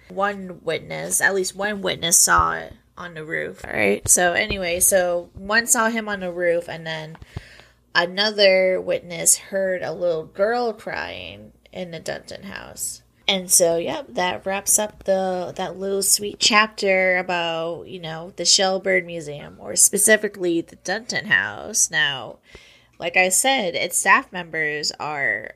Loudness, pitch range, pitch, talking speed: -19 LUFS, 170-200 Hz, 185 Hz, 155 wpm